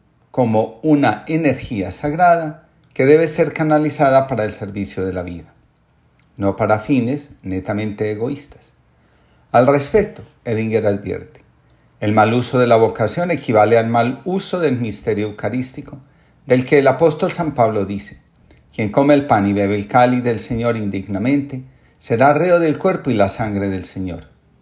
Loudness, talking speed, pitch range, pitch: -17 LUFS, 155 wpm, 105-145 Hz, 120 Hz